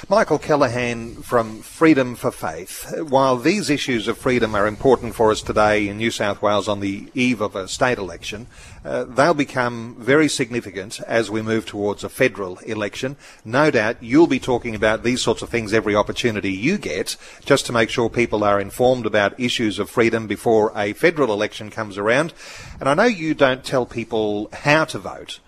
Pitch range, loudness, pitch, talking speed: 105-130 Hz, -20 LUFS, 115 Hz, 190 wpm